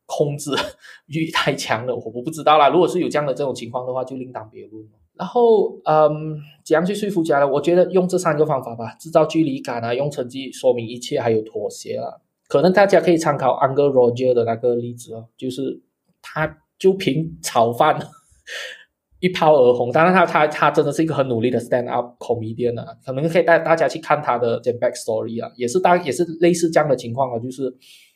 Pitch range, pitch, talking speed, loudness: 125-165 Hz, 150 Hz, 355 characters per minute, -19 LUFS